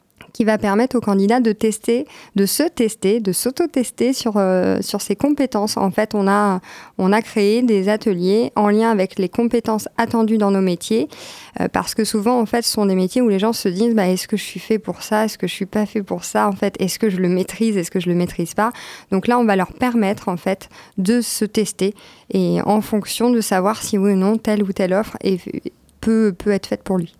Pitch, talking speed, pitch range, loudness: 210 Hz, 245 wpm, 190-225 Hz, -18 LUFS